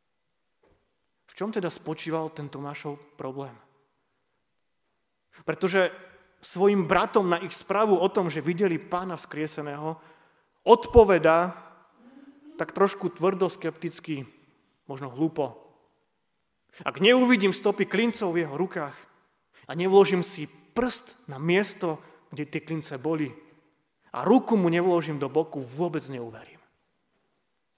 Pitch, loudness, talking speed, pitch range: 170 Hz, -25 LUFS, 110 wpm, 155-195 Hz